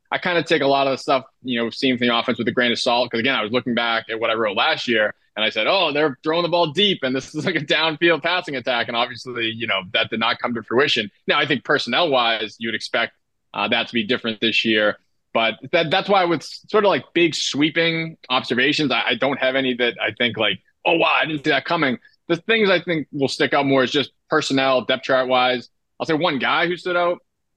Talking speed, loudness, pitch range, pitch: 255 wpm, -20 LUFS, 120-160 Hz, 130 Hz